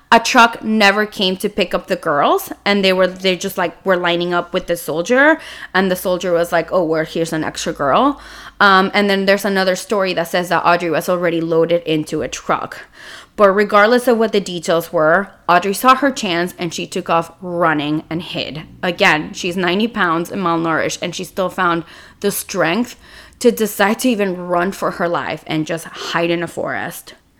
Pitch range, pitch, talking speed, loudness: 170-200 Hz, 185 Hz, 200 wpm, -16 LUFS